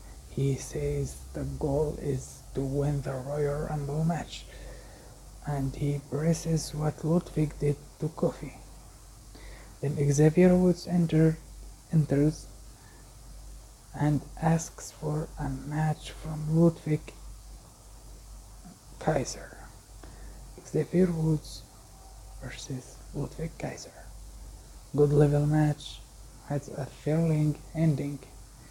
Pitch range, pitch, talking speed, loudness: 125-155 Hz, 145 Hz, 90 wpm, -29 LUFS